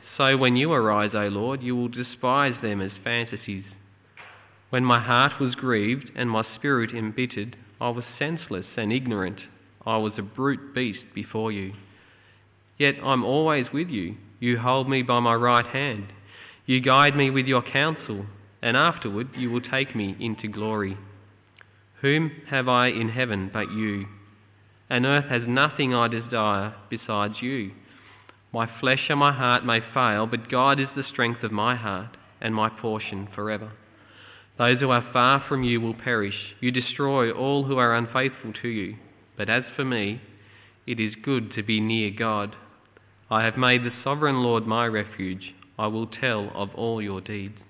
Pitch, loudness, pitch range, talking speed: 115 Hz, -24 LUFS, 105-125 Hz, 170 wpm